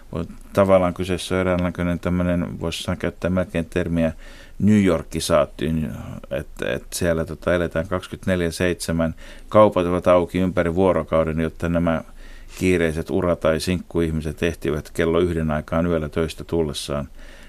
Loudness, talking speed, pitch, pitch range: -22 LUFS, 125 wpm, 85 Hz, 80-90 Hz